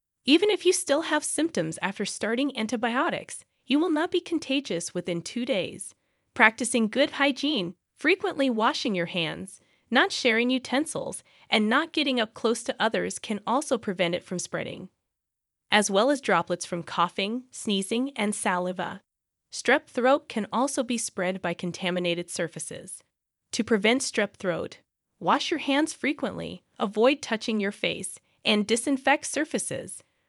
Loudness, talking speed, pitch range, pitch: -26 LUFS, 145 wpm, 195-280 Hz, 235 Hz